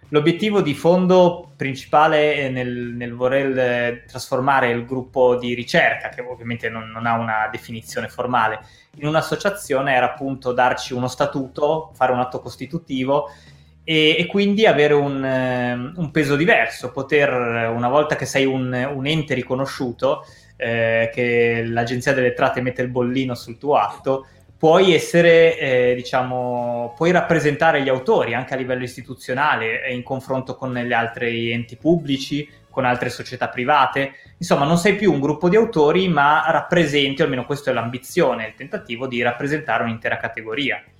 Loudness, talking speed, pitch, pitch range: -19 LUFS, 150 wpm, 130 Hz, 120-150 Hz